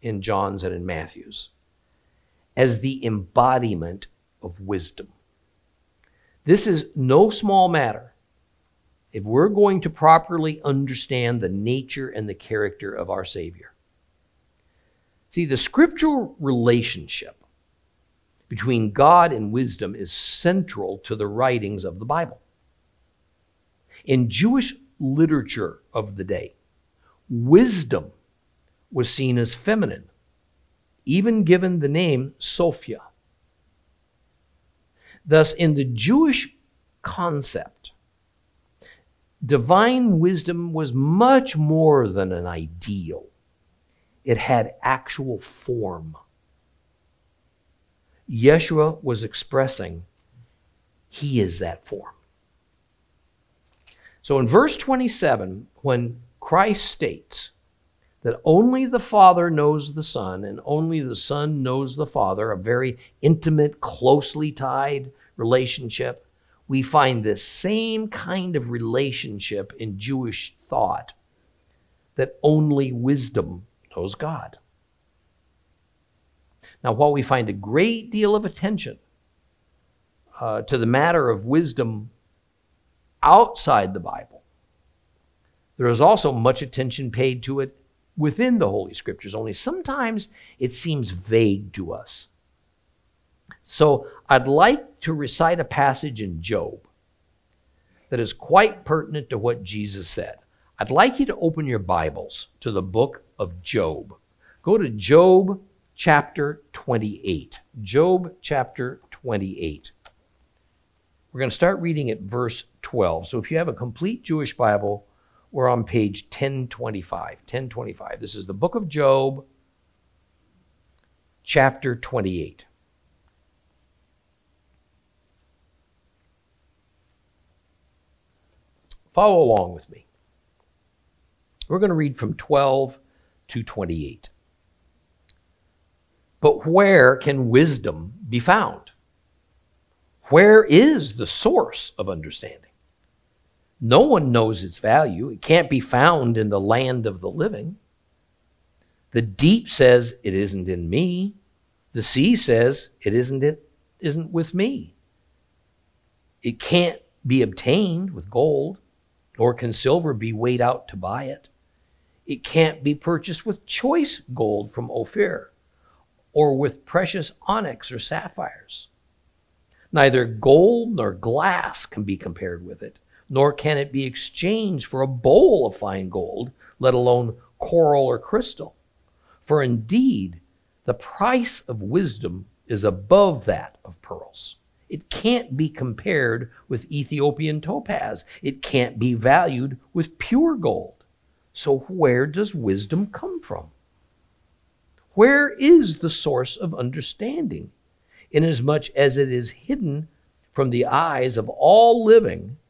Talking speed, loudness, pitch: 115 wpm, -21 LUFS, 125 Hz